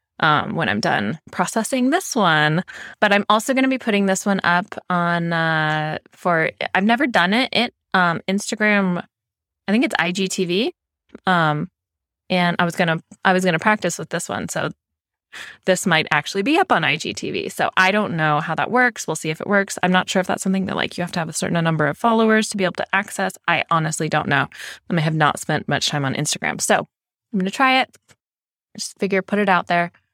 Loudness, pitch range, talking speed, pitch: -19 LUFS, 160-210 Hz, 215 wpm, 185 Hz